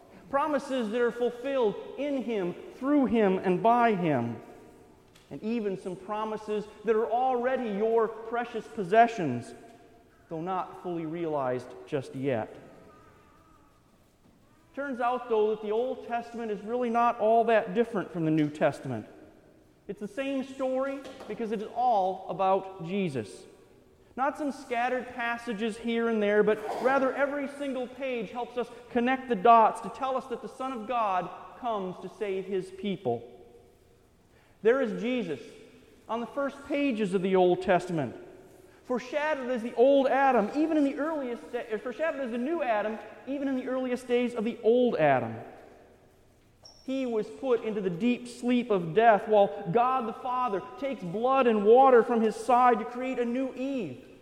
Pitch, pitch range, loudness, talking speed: 235 Hz, 205-255 Hz, -28 LUFS, 160 wpm